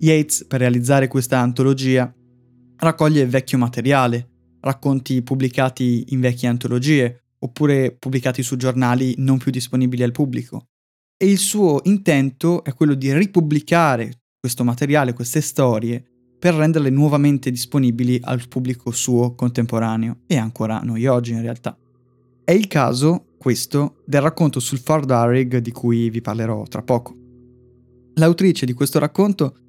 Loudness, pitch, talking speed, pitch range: -18 LUFS, 130 Hz, 135 wpm, 125-145 Hz